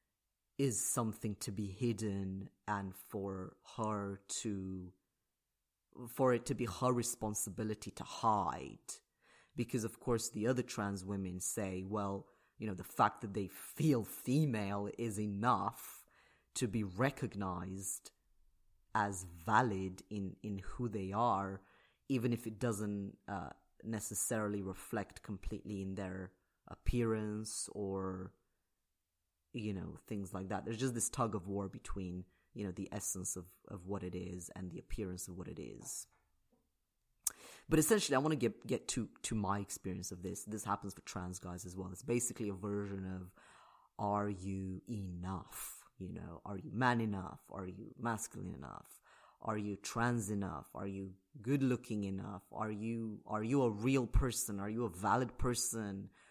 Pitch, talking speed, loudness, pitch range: 100 Hz, 155 wpm, -39 LUFS, 95-115 Hz